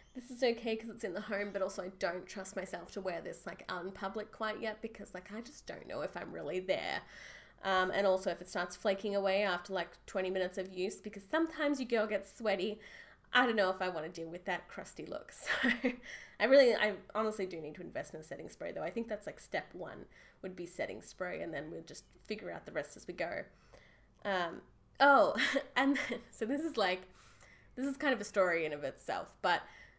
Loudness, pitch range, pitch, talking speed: -36 LUFS, 185-235 Hz, 205 Hz, 235 wpm